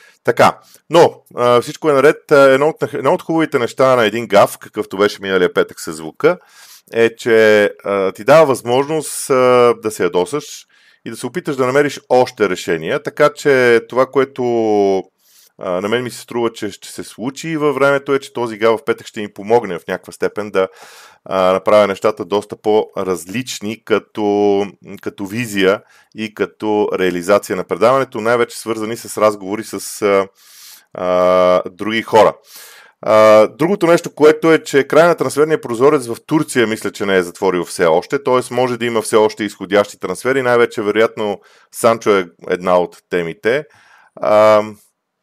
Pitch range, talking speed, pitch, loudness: 100-130 Hz, 160 wpm, 115 Hz, -15 LUFS